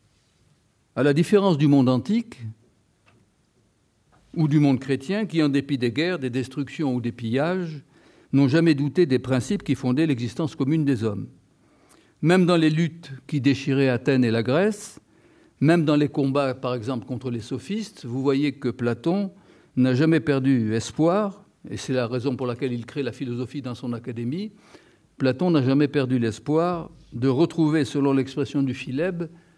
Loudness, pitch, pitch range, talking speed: -23 LUFS, 140 Hz, 125-160 Hz, 165 wpm